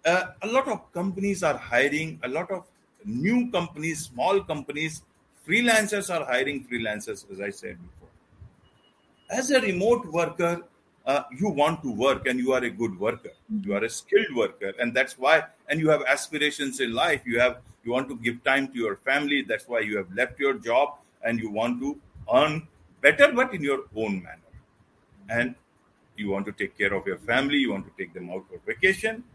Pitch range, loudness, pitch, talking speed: 125-205 Hz, -25 LUFS, 155 Hz, 195 wpm